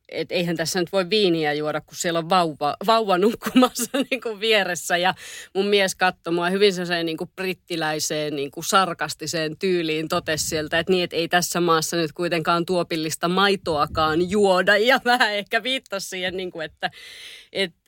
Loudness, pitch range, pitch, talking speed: -22 LUFS, 165-195 Hz, 175 Hz, 165 wpm